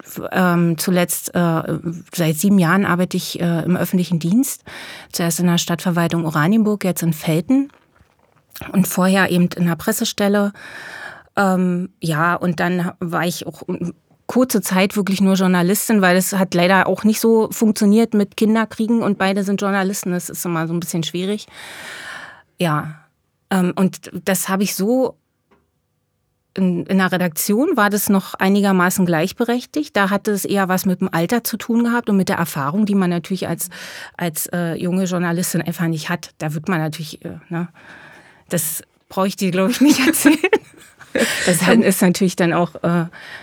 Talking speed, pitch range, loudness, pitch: 170 wpm, 170-200 Hz, -18 LUFS, 185 Hz